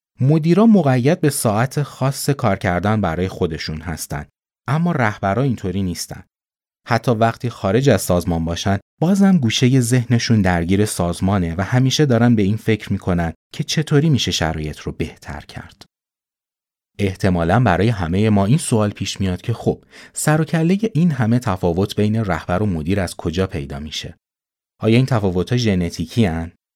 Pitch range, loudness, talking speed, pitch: 90-130 Hz, -18 LUFS, 150 wpm, 110 Hz